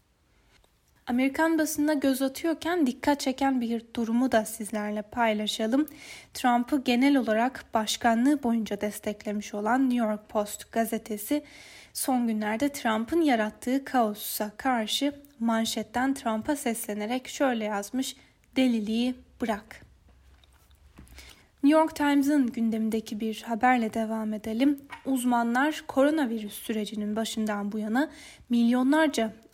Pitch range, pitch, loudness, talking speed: 215-270 Hz, 235 Hz, -27 LUFS, 100 wpm